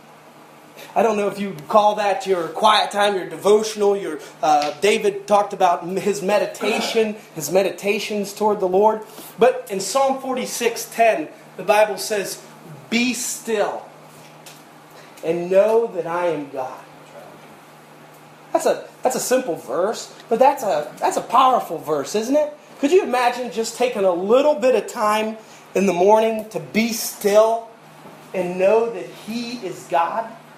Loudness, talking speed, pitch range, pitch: -20 LUFS, 150 wpm, 190-230 Hz, 210 Hz